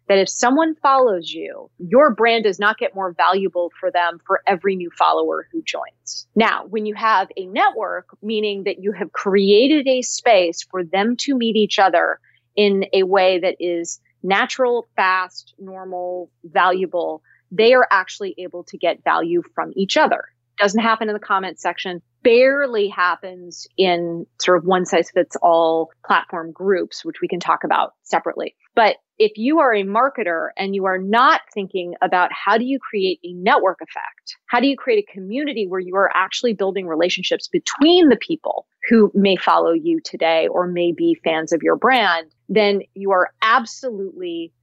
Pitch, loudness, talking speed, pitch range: 195 Hz, -18 LUFS, 175 wpm, 175-230 Hz